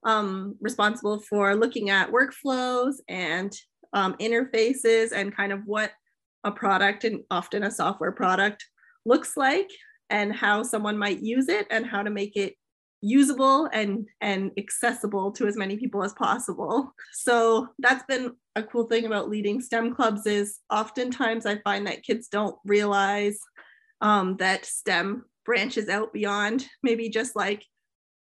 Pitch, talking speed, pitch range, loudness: 215 Hz, 150 wpm, 205-240 Hz, -25 LUFS